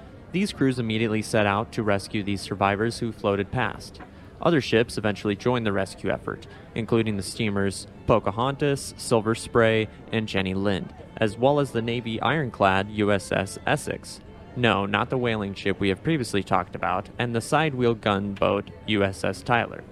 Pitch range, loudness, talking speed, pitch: 100-115 Hz, -25 LUFS, 160 wpm, 105 Hz